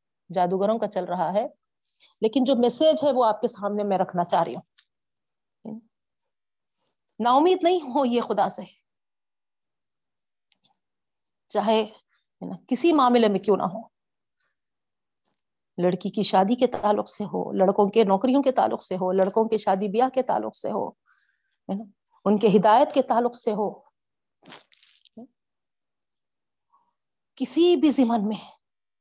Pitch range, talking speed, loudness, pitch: 195-250 Hz, 135 wpm, -23 LUFS, 220 Hz